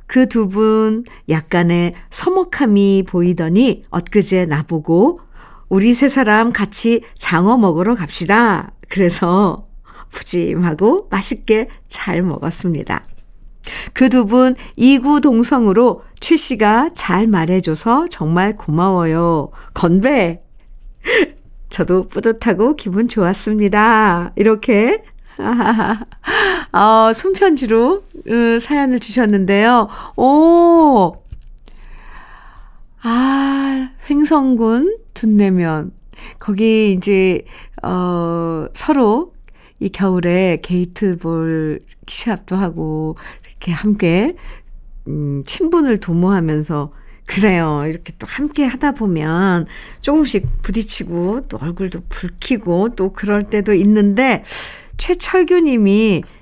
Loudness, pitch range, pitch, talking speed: -15 LUFS, 180-250 Hz, 210 Hz, 200 characters per minute